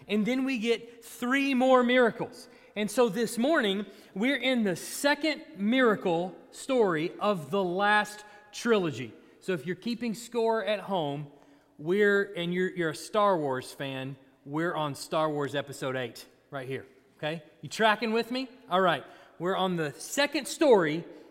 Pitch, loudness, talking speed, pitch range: 200 Hz, -28 LUFS, 160 wpm, 155-235 Hz